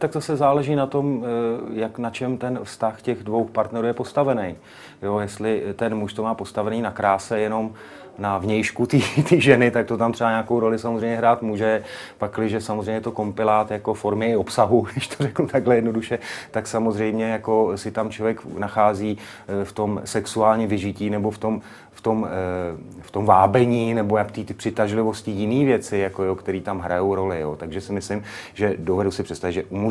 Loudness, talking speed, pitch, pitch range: -22 LUFS, 185 wpm, 110 Hz, 105-115 Hz